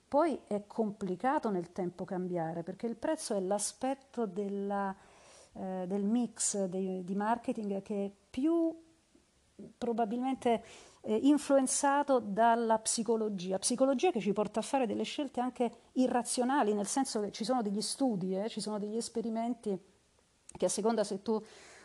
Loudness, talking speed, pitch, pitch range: -33 LUFS, 145 wpm, 225 Hz, 200-255 Hz